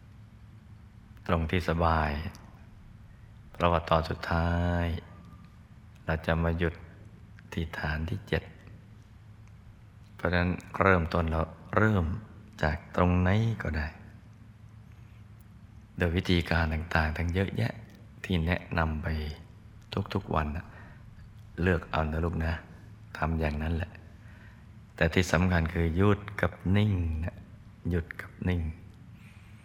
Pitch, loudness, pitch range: 95 Hz, -30 LUFS, 85-105 Hz